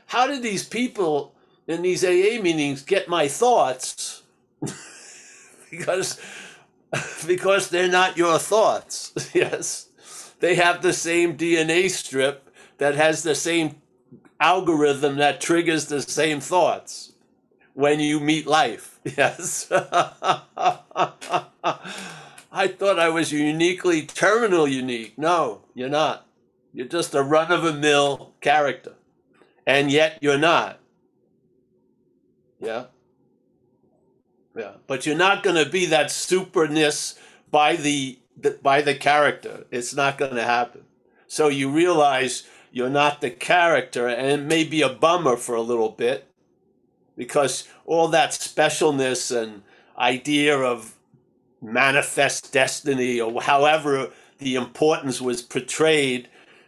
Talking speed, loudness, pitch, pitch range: 120 wpm, -21 LUFS, 150 Hz, 135-170 Hz